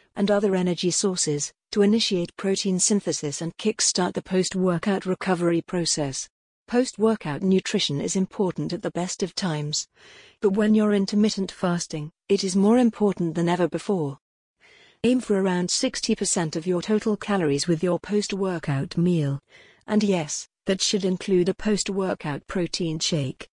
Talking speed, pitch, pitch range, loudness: 155 wpm, 185 Hz, 170-205 Hz, -24 LUFS